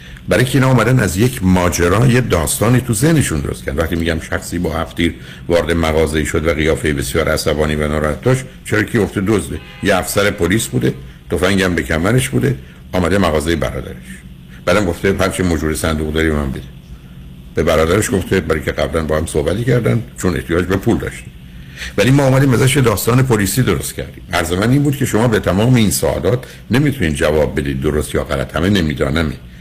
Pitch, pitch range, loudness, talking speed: 85 Hz, 75-110 Hz, -15 LUFS, 185 wpm